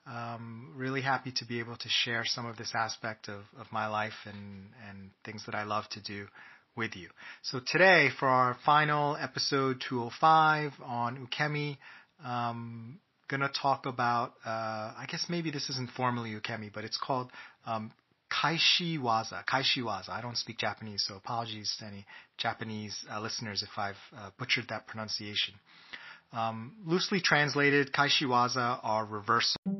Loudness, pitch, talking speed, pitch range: -31 LUFS, 120 Hz, 155 wpm, 110-135 Hz